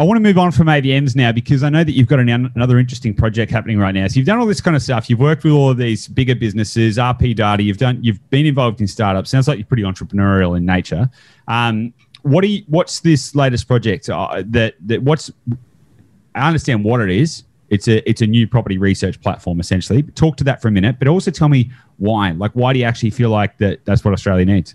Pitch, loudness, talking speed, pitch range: 120 Hz, -15 LUFS, 245 wpm, 105-135 Hz